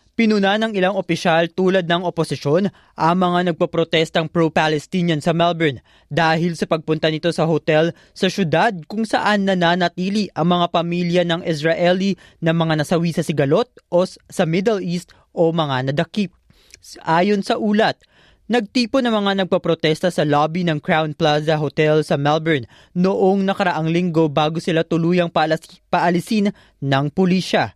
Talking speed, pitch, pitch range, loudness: 145 wpm, 170 Hz, 160-185 Hz, -19 LUFS